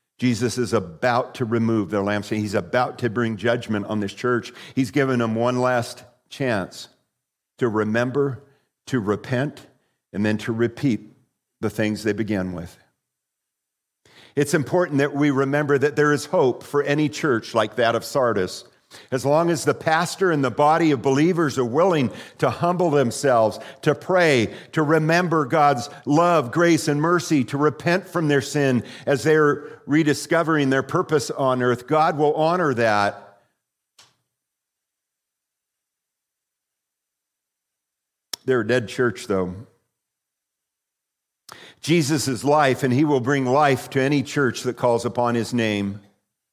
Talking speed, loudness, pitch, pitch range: 145 wpm, -21 LUFS, 135 Hz, 115-150 Hz